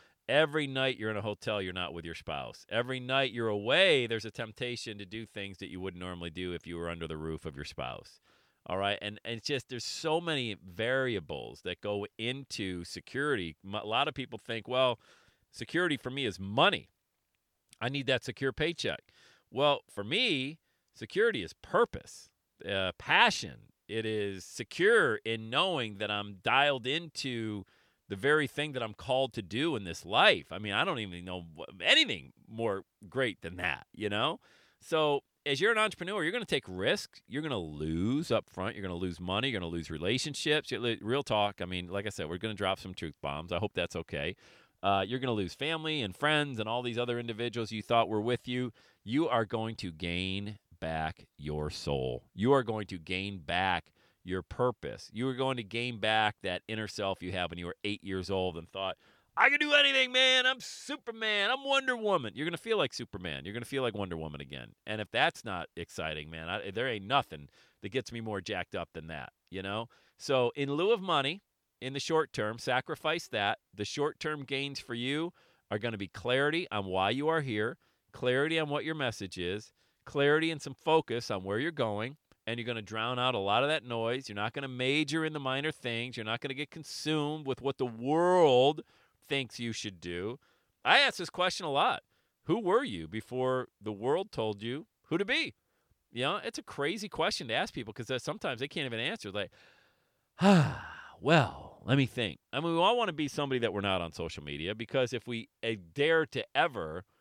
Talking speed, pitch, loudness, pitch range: 215 wpm, 115 Hz, -32 LUFS, 95-140 Hz